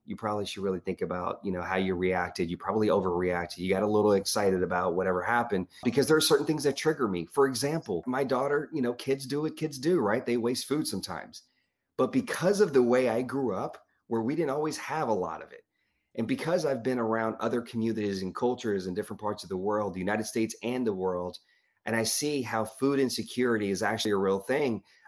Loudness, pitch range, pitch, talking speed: -29 LUFS, 95-135 Hz, 115 Hz, 225 wpm